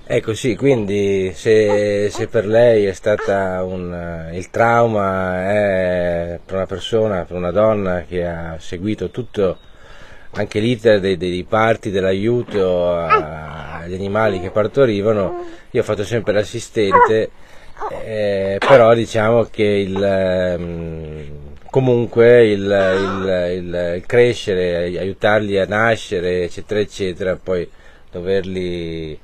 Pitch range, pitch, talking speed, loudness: 90-110 Hz, 100 Hz, 115 wpm, -17 LUFS